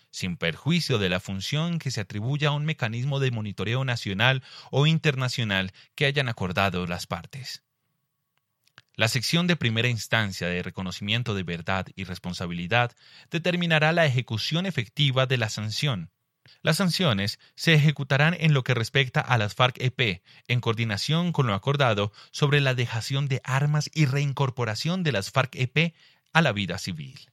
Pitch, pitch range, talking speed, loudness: 130 Hz, 105-145 Hz, 150 wpm, -25 LUFS